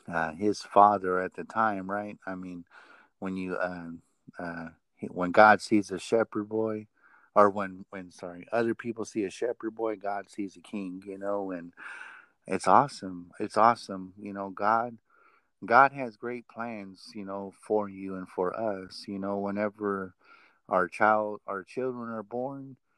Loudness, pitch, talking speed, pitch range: -29 LUFS, 100 Hz, 165 wpm, 95-110 Hz